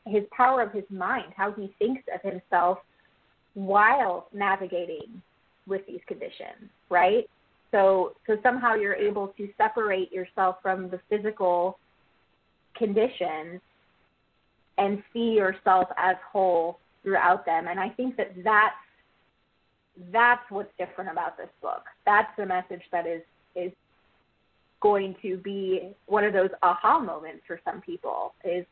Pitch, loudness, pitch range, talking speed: 195 Hz, -26 LUFS, 185-215 Hz, 135 wpm